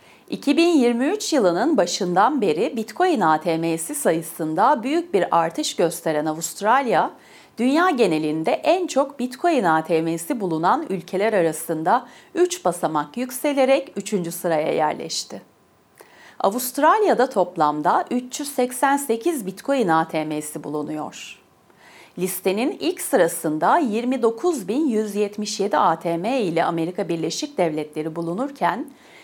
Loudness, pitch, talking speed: -21 LUFS, 205 Hz, 90 wpm